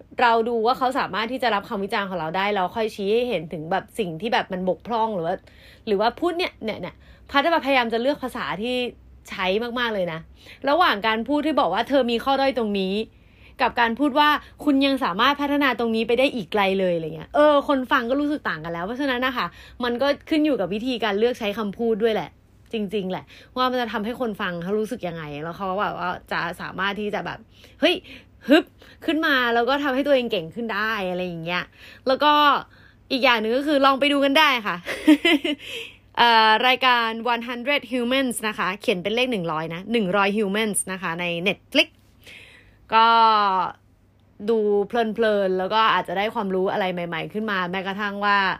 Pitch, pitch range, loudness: 230 Hz, 195-260 Hz, -22 LUFS